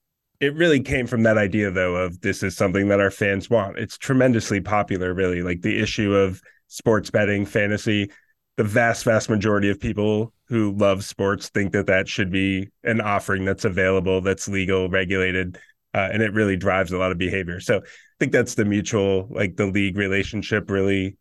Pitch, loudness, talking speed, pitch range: 100 Hz, -22 LUFS, 190 wpm, 95-110 Hz